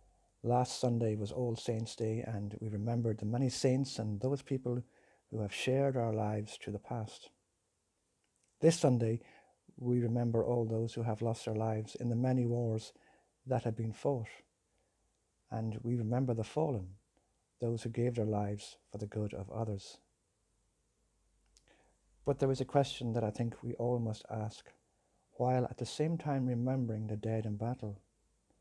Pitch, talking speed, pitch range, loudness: 115 Hz, 165 wpm, 110-125 Hz, -36 LUFS